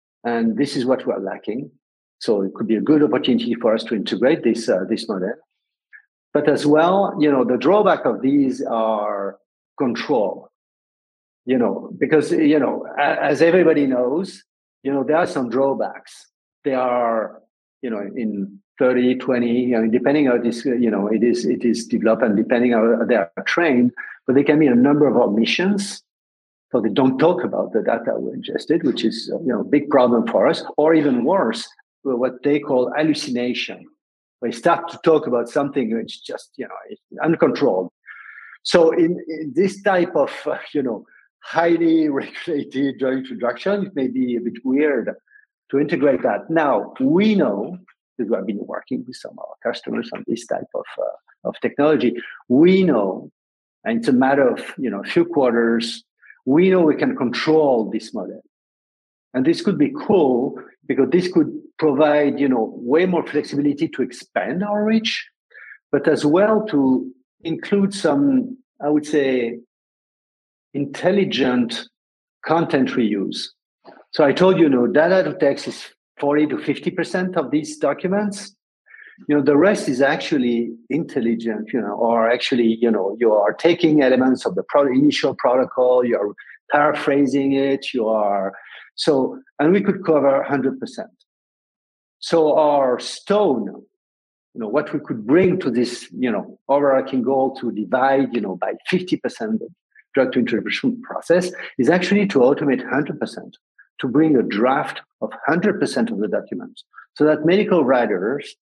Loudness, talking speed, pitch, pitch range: -19 LUFS, 170 wpm, 145 Hz, 125-185 Hz